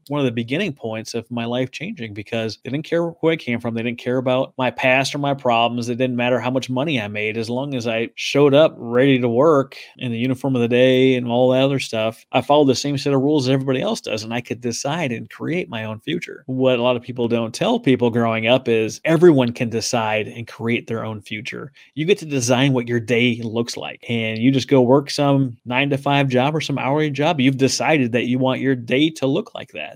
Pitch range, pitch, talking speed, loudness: 115-135 Hz, 125 Hz, 255 wpm, -19 LUFS